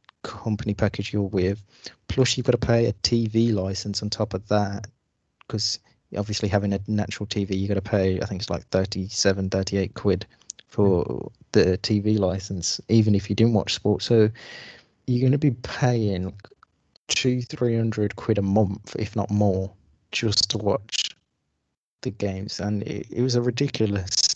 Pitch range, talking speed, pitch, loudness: 100-115 Hz, 170 wpm, 105 Hz, -24 LUFS